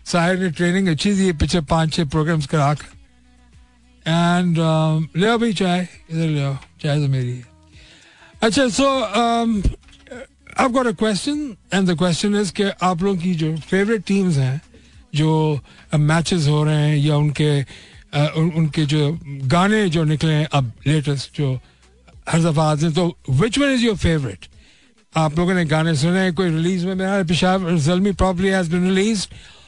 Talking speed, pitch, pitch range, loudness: 125 wpm, 165 Hz, 150-190 Hz, -19 LUFS